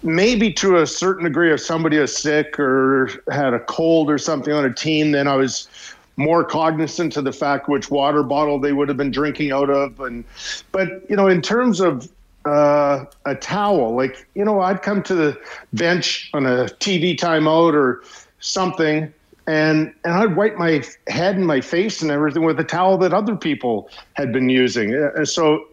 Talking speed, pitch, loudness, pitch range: 190 wpm, 155 Hz, -18 LUFS, 140-175 Hz